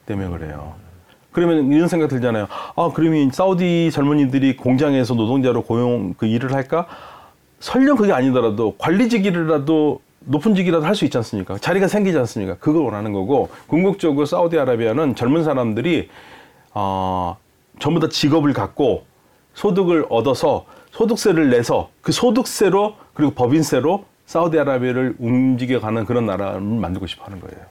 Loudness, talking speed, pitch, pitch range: -18 LUFS, 365 characters per minute, 135 Hz, 110-165 Hz